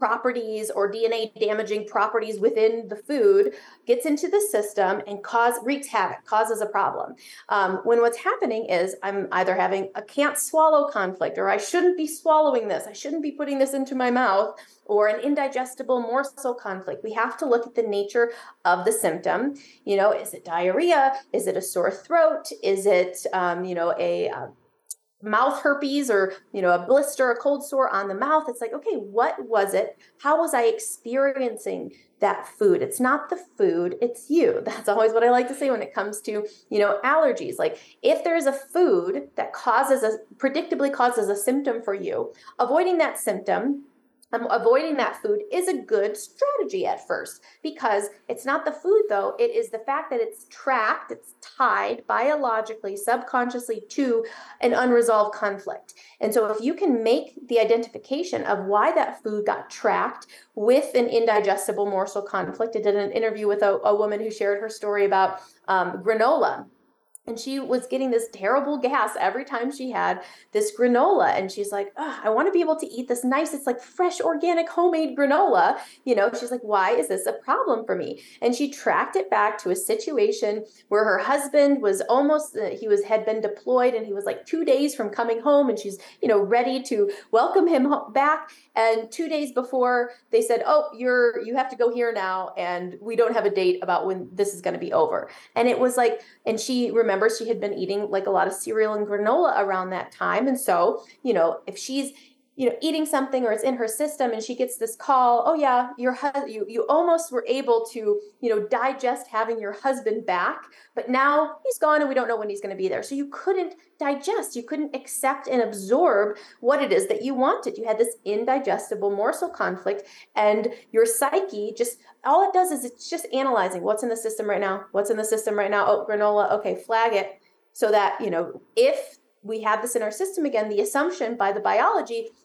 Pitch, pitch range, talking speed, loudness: 245 Hz, 215-295 Hz, 200 wpm, -23 LUFS